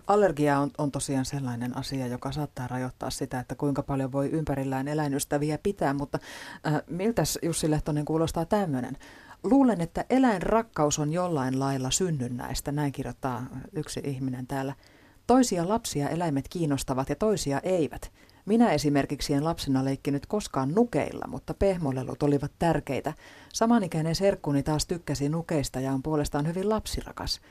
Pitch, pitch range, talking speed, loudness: 145 Hz, 135-170 Hz, 140 wpm, -28 LUFS